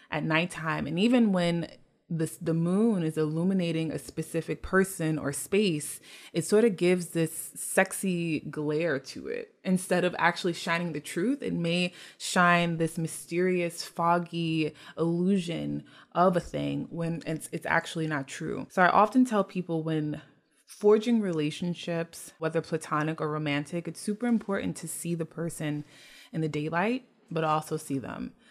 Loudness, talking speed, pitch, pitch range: -29 LUFS, 150 wpm, 165 Hz, 155-180 Hz